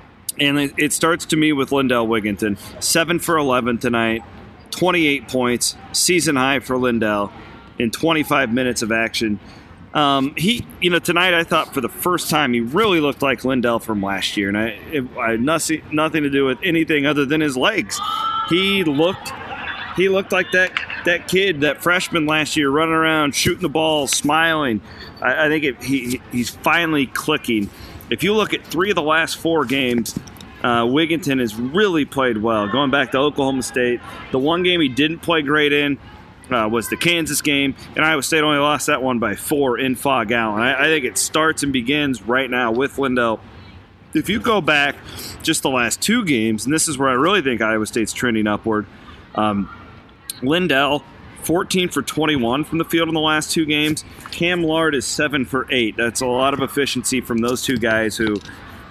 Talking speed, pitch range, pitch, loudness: 195 wpm, 115-160 Hz, 135 Hz, -18 LUFS